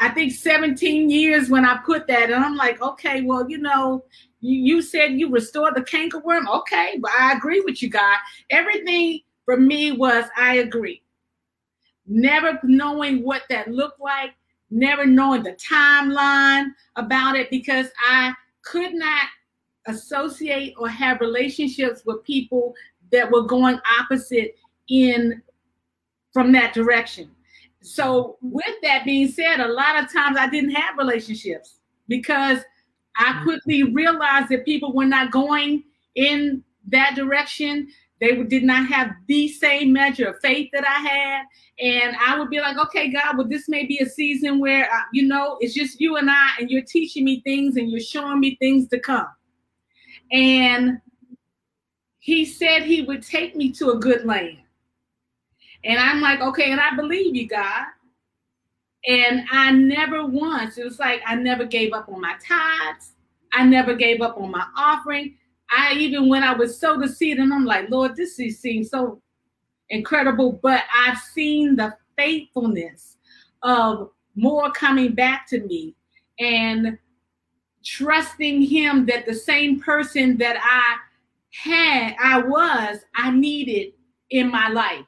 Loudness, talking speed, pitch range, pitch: -19 LUFS, 155 wpm, 245-290 Hz, 265 Hz